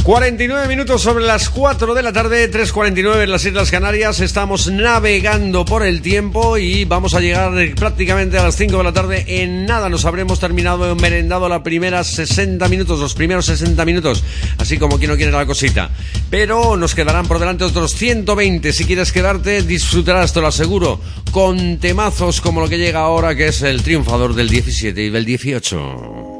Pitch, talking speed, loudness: 120 Hz, 185 wpm, -14 LUFS